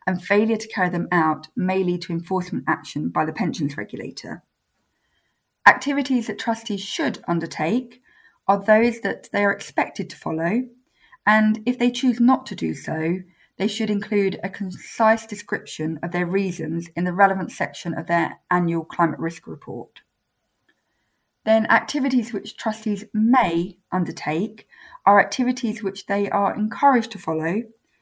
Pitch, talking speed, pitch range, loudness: 200 Hz, 150 wpm, 175-225 Hz, -22 LUFS